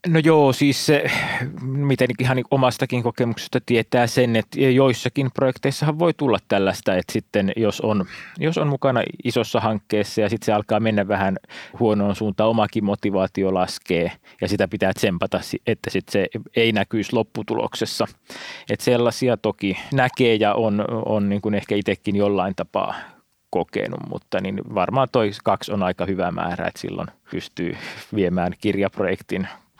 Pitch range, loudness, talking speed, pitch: 100-125 Hz, -21 LUFS, 150 wpm, 110 Hz